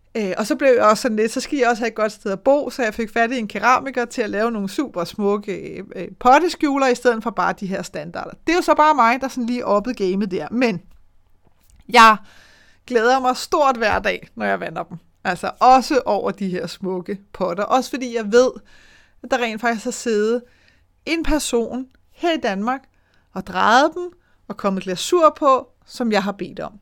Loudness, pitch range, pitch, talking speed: -19 LUFS, 205-260 Hz, 240 Hz, 215 wpm